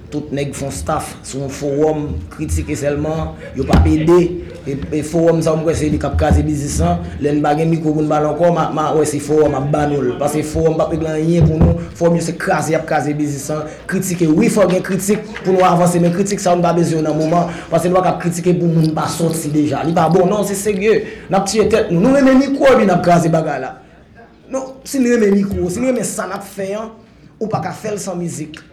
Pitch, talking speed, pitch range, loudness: 165 Hz, 105 wpm, 150-190 Hz, -16 LUFS